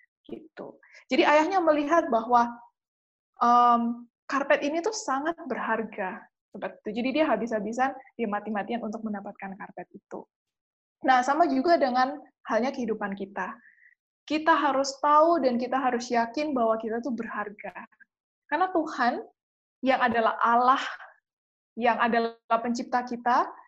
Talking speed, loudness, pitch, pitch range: 120 wpm, -26 LUFS, 250 Hz, 230-300 Hz